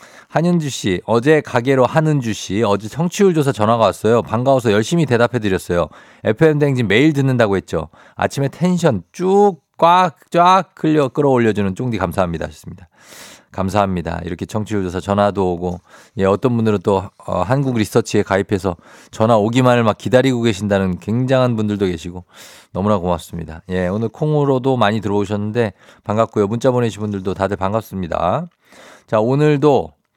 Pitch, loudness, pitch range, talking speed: 110 Hz, -17 LUFS, 95-135 Hz, 370 characters per minute